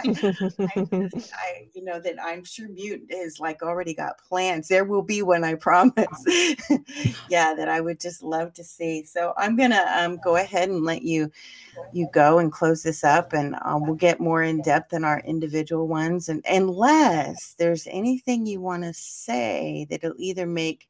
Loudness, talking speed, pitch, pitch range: -23 LUFS, 185 wpm, 175 Hz, 160-190 Hz